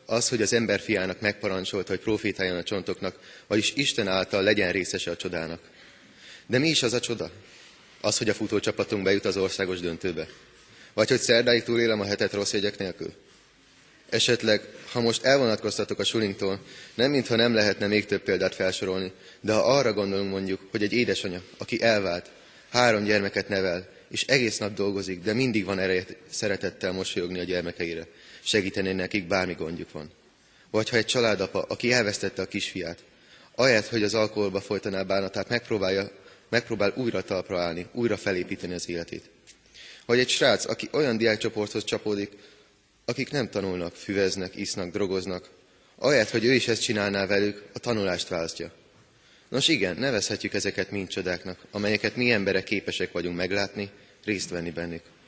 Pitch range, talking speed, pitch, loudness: 95-110 Hz, 155 wpm, 100 Hz, -26 LUFS